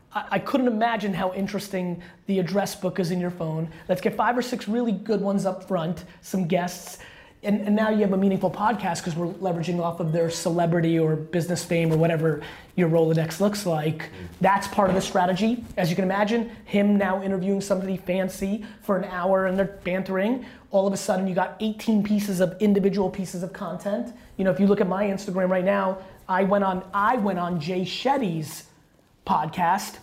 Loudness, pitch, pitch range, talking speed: -24 LUFS, 190 Hz, 180-205 Hz, 200 wpm